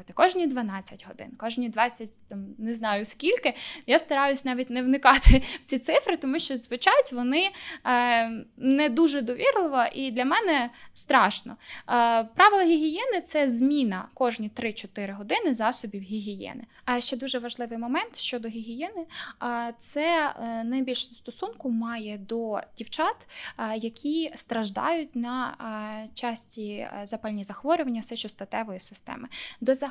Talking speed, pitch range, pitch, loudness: 120 wpm, 225-290 Hz, 245 Hz, -26 LUFS